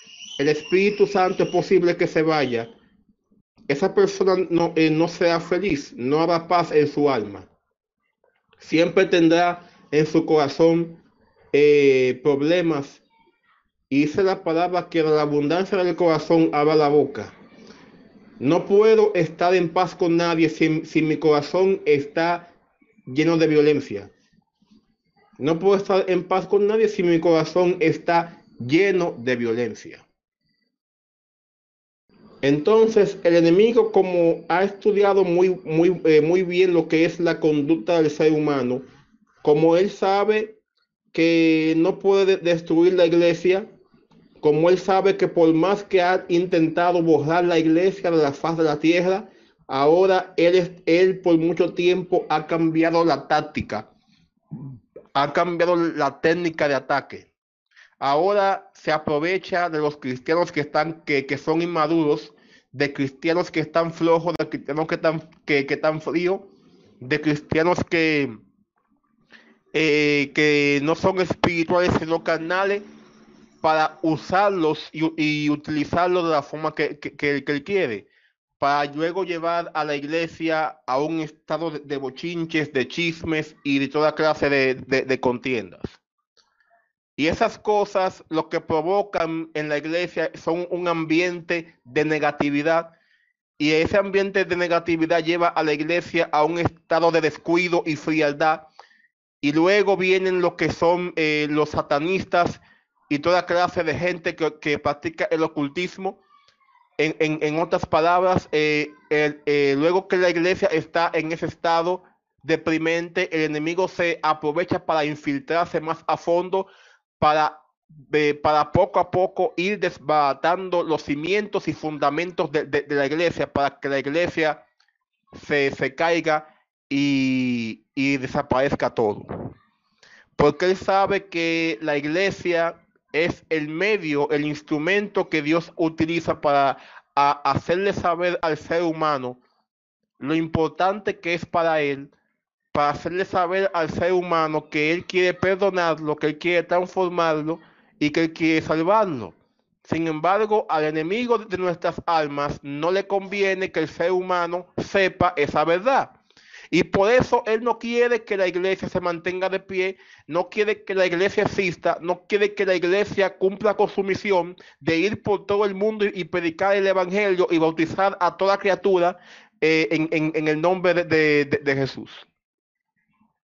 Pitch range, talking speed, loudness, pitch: 155-185 Hz, 145 wpm, -21 LUFS, 170 Hz